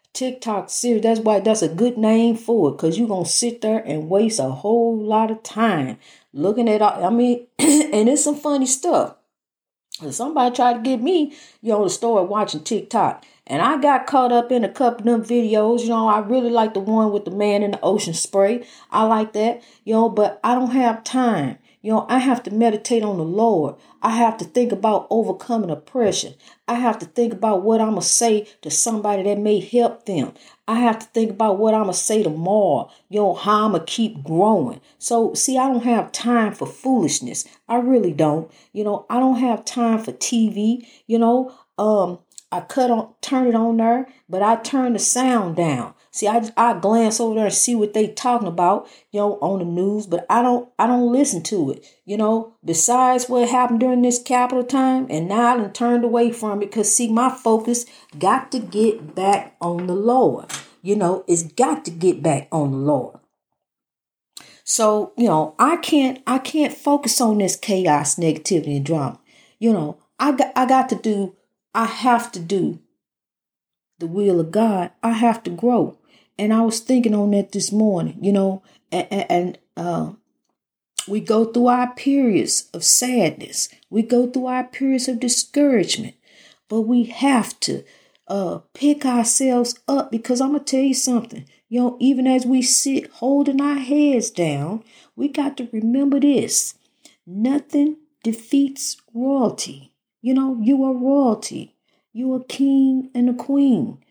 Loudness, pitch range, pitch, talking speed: -19 LUFS, 205-255 Hz, 230 Hz, 190 wpm